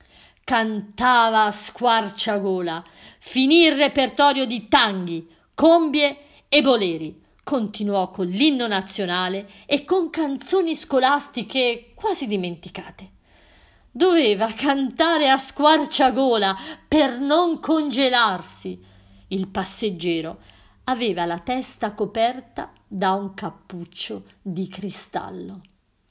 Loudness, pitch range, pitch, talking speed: -20 LUFS, 185-275 Hz, 225 Hz, 90 wpm